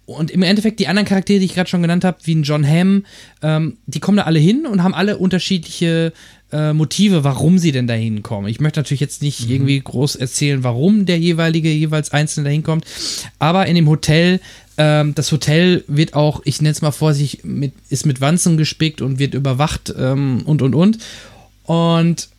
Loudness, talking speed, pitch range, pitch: -16 LUFS, 205 wpm, 140-175 Hz, 155 Hz